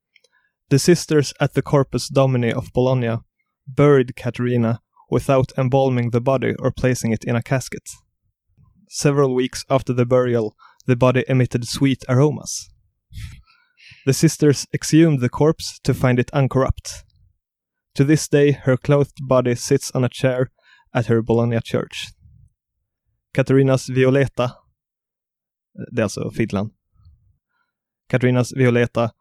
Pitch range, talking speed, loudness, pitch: 120-140 Hz, 120 wpm, -19 LUFS, 130 Hz